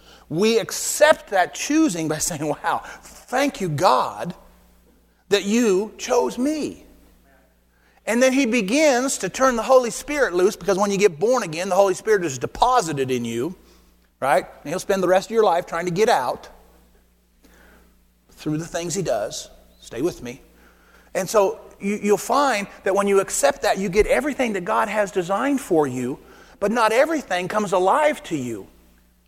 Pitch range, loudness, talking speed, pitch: 150-240 Hz, -21 LUFS, 170 wpm, 195 Hz